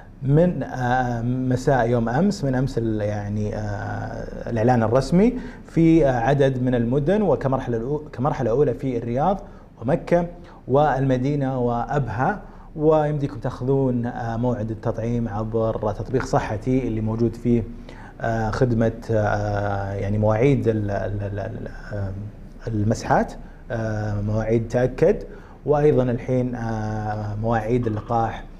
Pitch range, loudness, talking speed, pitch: 110-135 Hz, -22 LUFS, 85 wpm, 120 Hz